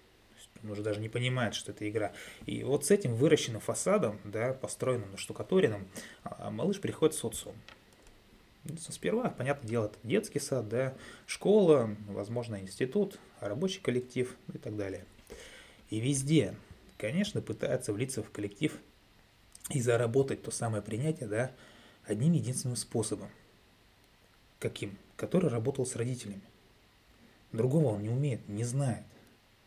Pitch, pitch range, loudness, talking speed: 115 Hz, 105-130 Hz, -33 LUFS, 125 wpm